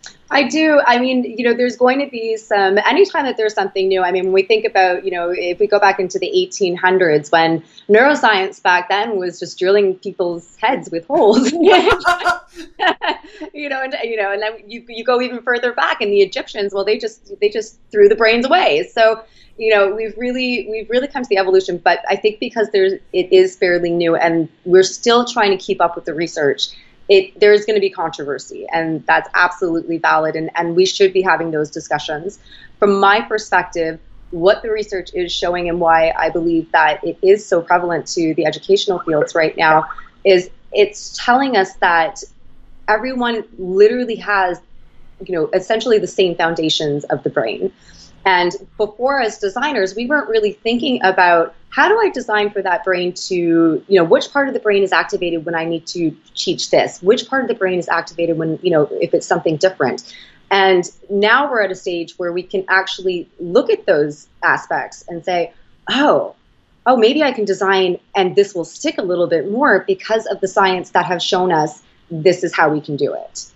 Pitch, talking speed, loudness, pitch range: 195 Hz, 200 wpm, -16 LUFS, 175-245 Hz